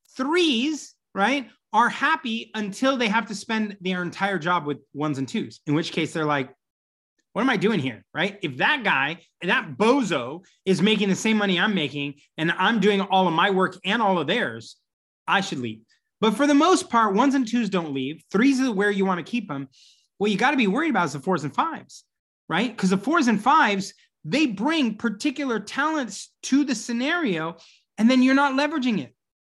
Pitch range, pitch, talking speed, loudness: 170-255 Hz, 205 Hz, 210 wpm, -23 LUFS